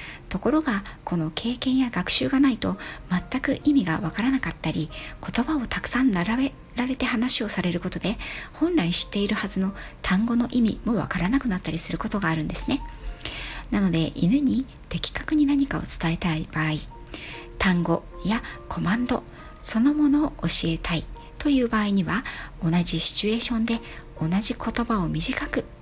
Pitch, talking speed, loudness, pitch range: 215 Hz, 330 characters per minute, -23 LUFS, 170-250 Hz